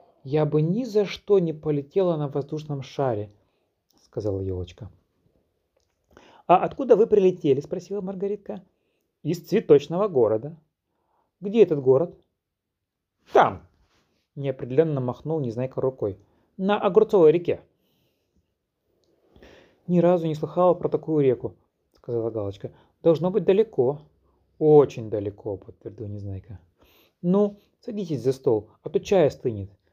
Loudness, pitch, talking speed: -23 LUFS, 145 Hz, 110 wpm